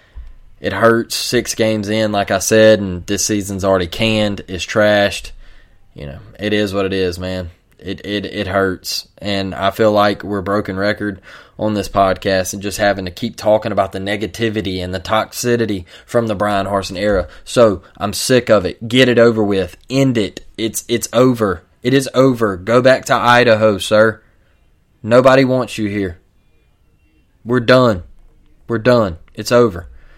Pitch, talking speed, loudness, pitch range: 105 Hz, 170 wpm, -15 LUFS, 95-110 Hz